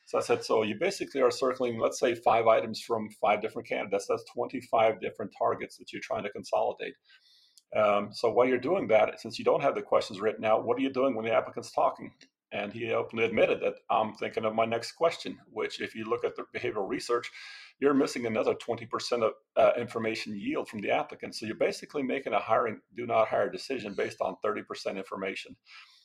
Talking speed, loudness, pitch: 210 wpm, -30 LUFS, 120 Hz